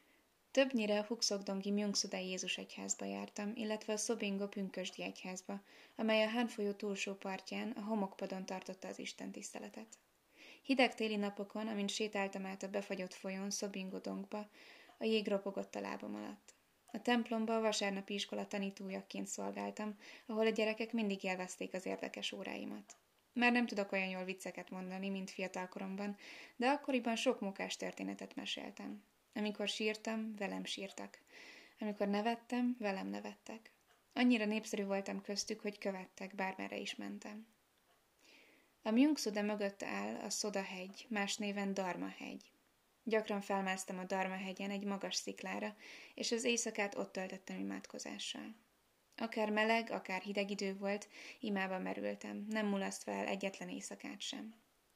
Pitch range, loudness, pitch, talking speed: 190-220 Hz, -40 LUFS, 200 Hz, 135 wpm